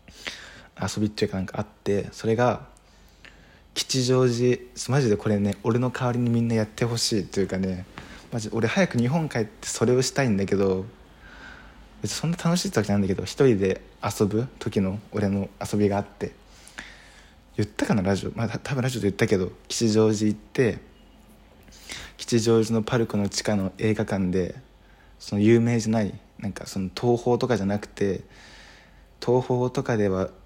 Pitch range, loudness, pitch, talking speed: 100-120 Hz, -25 LUFS, 110 Hz, 335 characters per minute